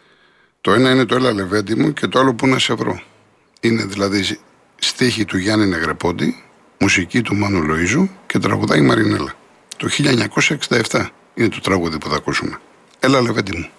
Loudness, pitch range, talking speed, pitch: -17 LUFS, 95-125 Hz, 165 wpm, 105 Hz